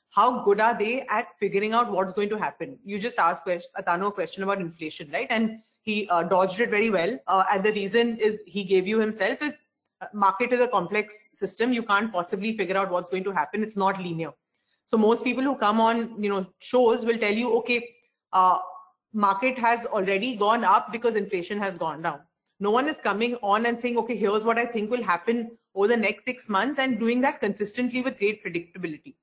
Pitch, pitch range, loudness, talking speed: 210 Hz, 195-235 Hz, -25 LUFS, 215 wpm